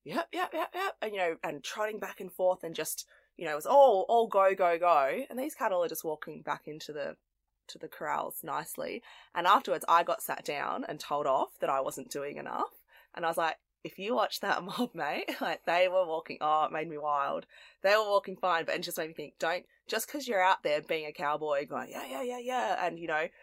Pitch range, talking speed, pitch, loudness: 160-240 Hz, 250 wpm, 185 Hz, -31 LUFS